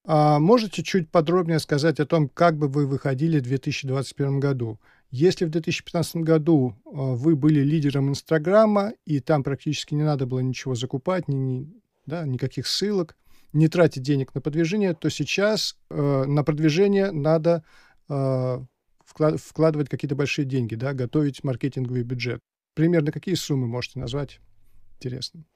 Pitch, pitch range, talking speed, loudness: 150 Hz, 135-165 Hz, 130 wpm, -23 LUFS